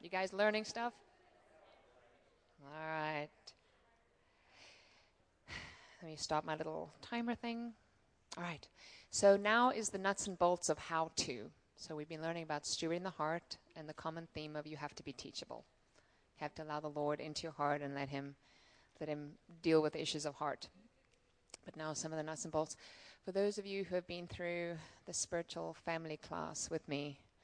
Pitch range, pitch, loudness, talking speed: 150-180 Hz, 160 Hz, -40 LUFS, 185 wpm